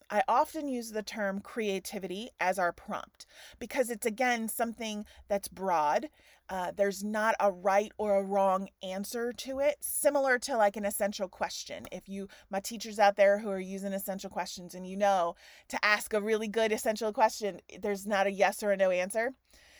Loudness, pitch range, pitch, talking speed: -31 LUFS, 195-225 Hz, 205 Hz, 185 wpm